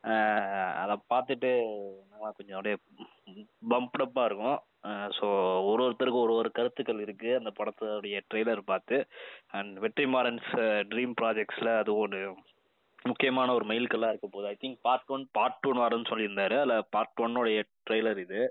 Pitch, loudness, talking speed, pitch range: 115 Hz, -30 LUFS, 140 wpm, 105-125 Hz